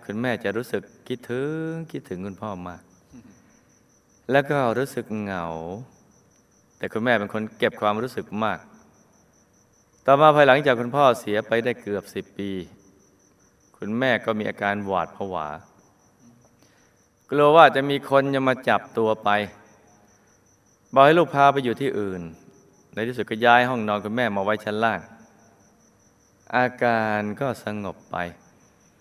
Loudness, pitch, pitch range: -22 LUFS, 110 Hz, 100-125 Hz